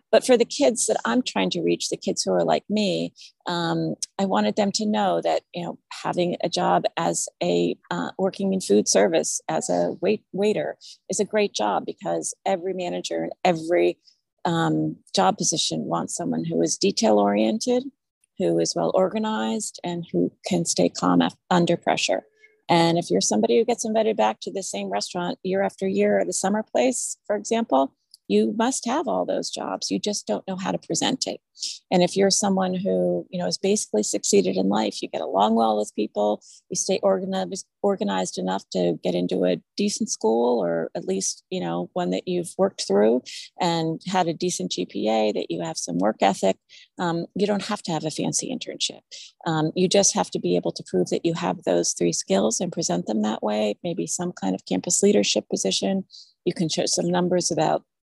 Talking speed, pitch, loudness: 200 wpm, 175 Hz, -23 LUFS